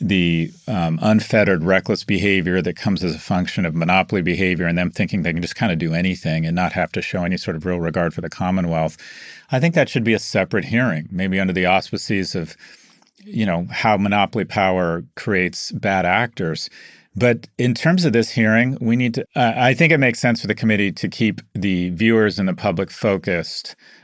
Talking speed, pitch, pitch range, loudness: 205 wpm, 95 Hz, 90-115 Hz, -19 LUFS